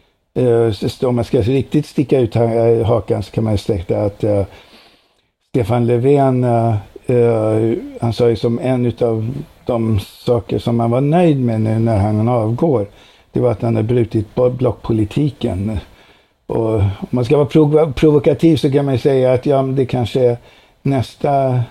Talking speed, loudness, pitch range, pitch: 145 wpm, -16 LUFS, 110-130 Hz, 120 Hz